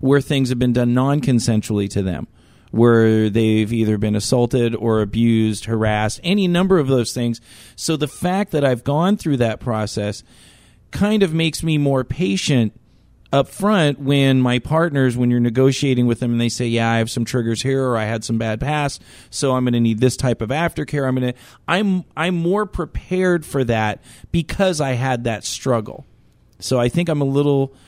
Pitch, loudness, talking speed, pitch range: 130 Hz, -19 LUFS, 195 wpm, 115-150 Hz